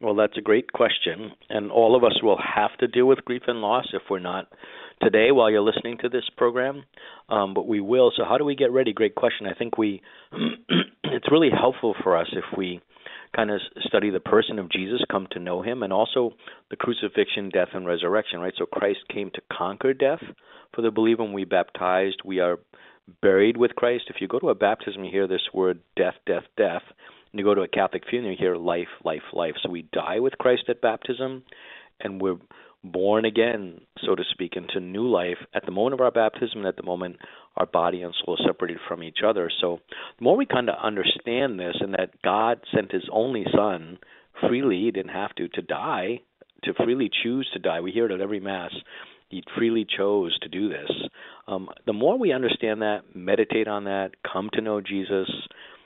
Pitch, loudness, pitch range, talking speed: 105 Hz, -24 LUFS, 95-120 Hz, 210 wpm